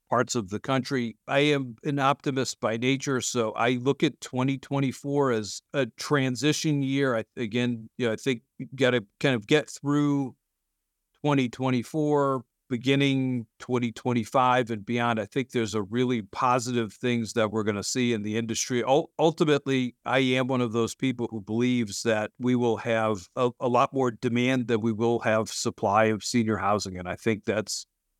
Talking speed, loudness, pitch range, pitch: 175 wpm, -26 LUFS, 115-135 Hz, 125 Hz